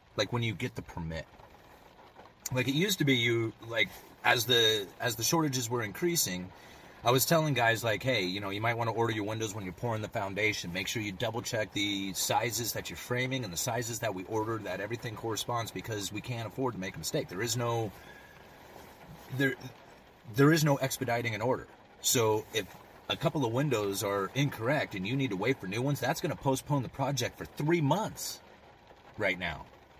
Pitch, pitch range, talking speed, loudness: 120 Hz, 105-135 Hz, 210 wpm, -31 LUFS